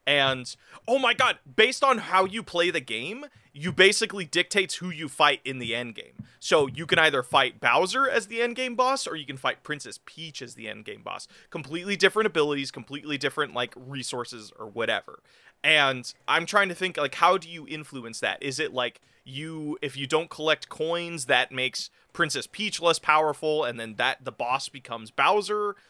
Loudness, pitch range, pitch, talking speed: -25 LUFS, 135-185 Hz, 155 Hz, 195 wpm